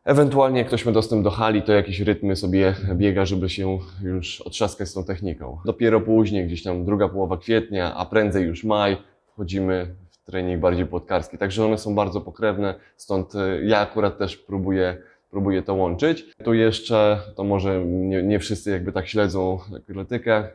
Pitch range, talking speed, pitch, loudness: 95-105 Hz, 170 wpm, 100 Hz, -22 LUFS